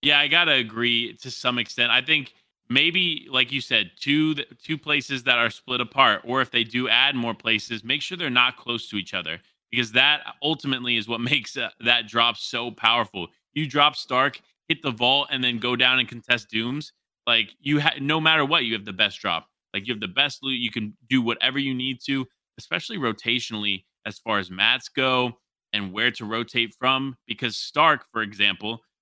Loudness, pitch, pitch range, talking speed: -22 LUFS, 125 Hz, 115-140 Hz, 205 wpm